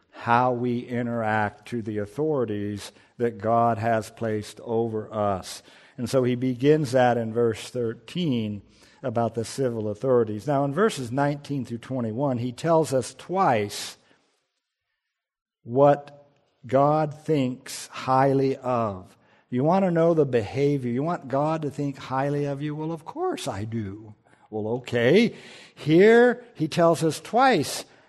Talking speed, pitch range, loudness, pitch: 140 wpm, 115-145 Hz, -24 LUFS, 130 Hz